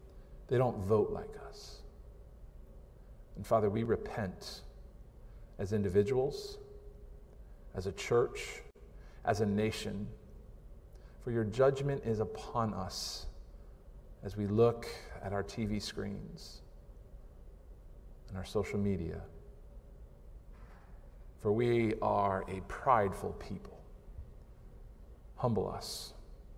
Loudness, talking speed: -35 LUFS, 95 wpm